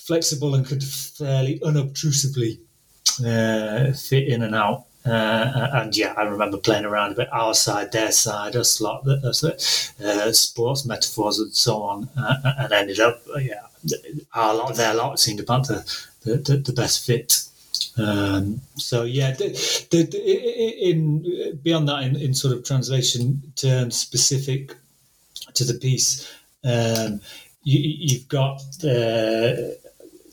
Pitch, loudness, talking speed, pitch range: 130 Hz, -21 LUFS, 145 wpm, 115-145 Hz